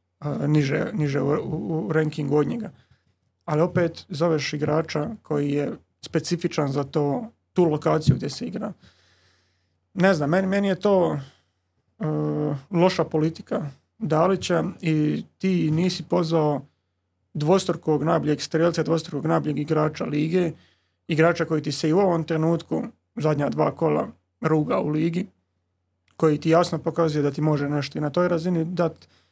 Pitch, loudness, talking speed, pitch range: 155 Hz, -24 LUFS, 145 wpm, 145-170 Hz